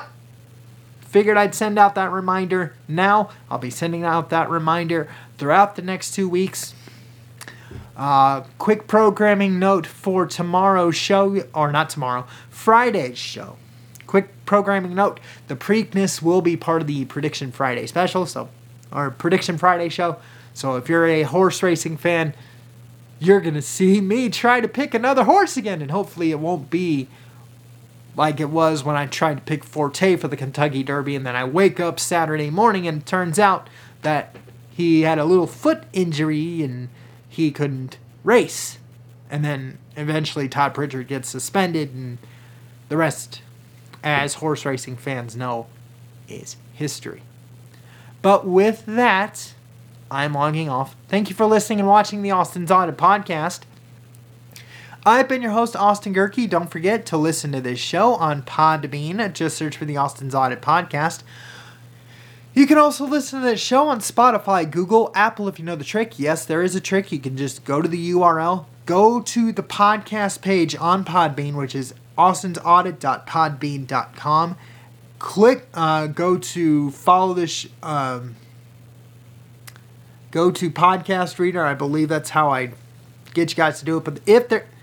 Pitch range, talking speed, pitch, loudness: 125-185 Hz, 160 wpm, 155 Hz, -20 LUFS